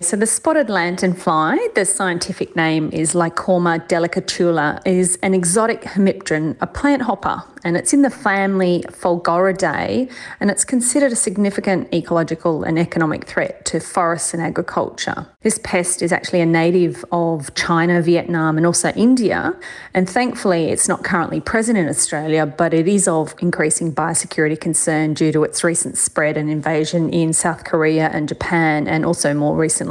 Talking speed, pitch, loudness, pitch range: 160 wpm, 175 Hz, -17 LUFS, 160-195 Hz